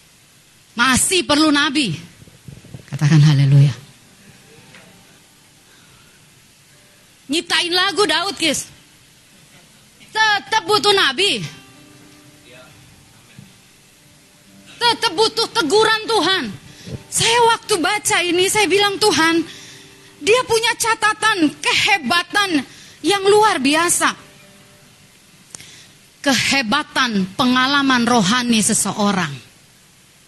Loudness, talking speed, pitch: -16 LUFS, 65 wpm, 325 Hz